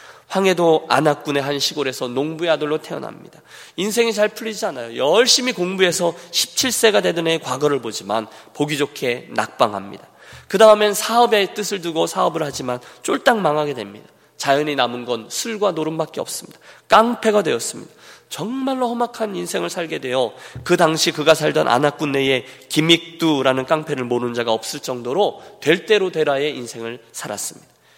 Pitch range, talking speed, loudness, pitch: 130-205 Hz, 360 characters per minute, -19 LUFS, 155 Hz